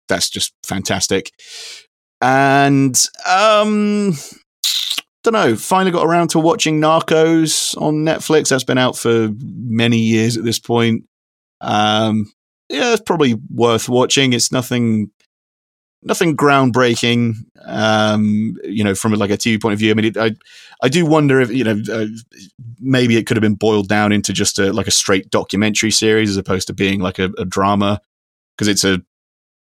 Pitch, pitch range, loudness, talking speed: 115 Hz, 105-140 Hz, -15 LUFS, 165 wpm